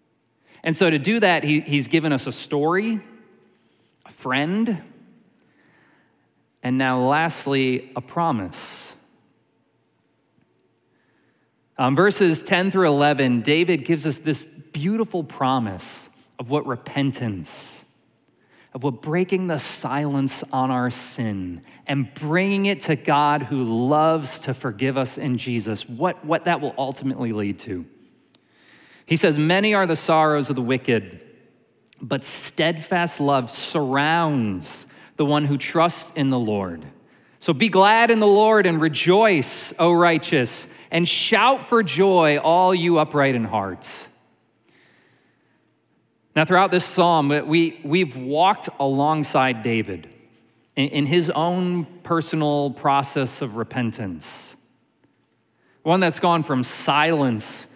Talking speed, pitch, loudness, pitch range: 125 wpm, 150 Hz, -21 LUFS, 130-170 Hz